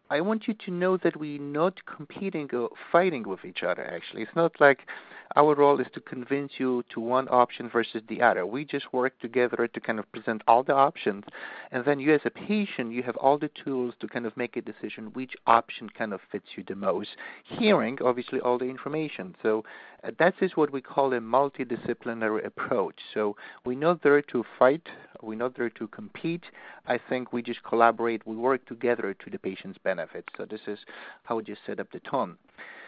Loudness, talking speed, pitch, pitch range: -27 LUFS, 205 wpm, 125 Hz, 115-145 Hz